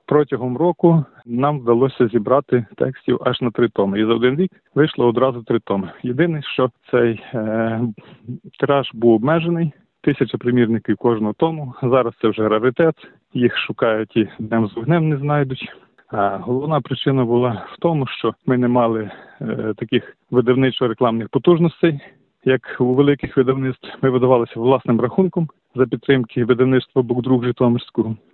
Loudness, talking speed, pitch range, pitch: -18 LUFS, 145 wpm, 120-145 Hz, 125 Hz